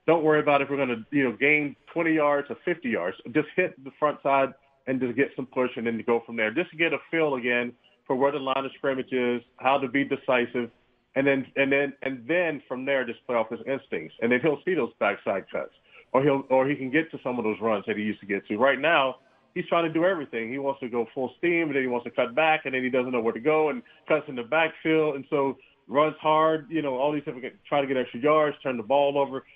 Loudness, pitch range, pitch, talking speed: -26 LUFS, 125-150 Hz, 135 Hz, 270 wpm